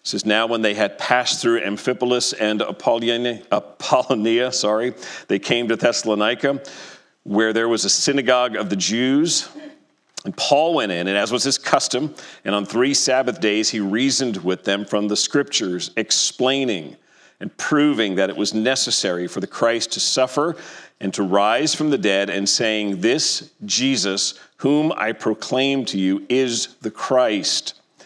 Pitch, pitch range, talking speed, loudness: 120 Hz, 105-135 Hz, 165 wpm, -19 LUFS